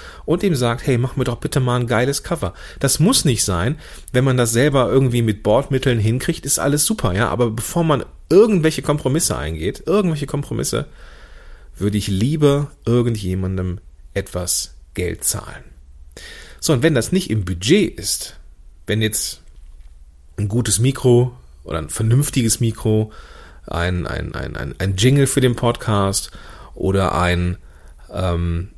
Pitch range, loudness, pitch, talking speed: 90-135 Hz, -18 LUFS, 110 Hz, 150 wpm